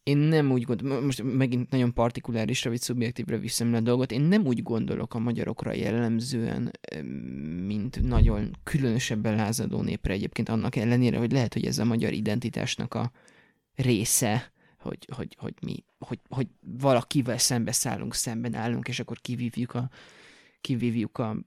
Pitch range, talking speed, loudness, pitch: 115-125 Hz, 155 wpm, -27 LUFS, 120 Hz